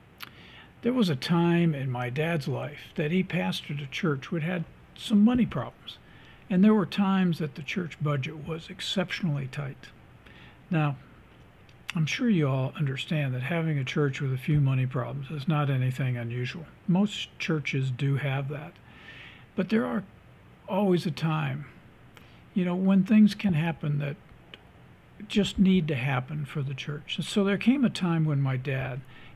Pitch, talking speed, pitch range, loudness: 155 Hz, 165 wpm, 140-185 Hz, -28 LUFS